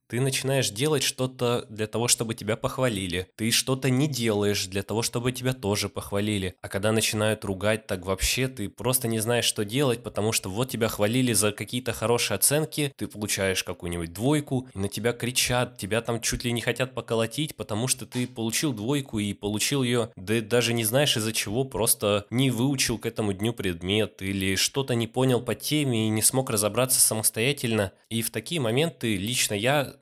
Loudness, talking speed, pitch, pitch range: -25 LUFS, 190 wpm, 115 Hz, 105-130 Hz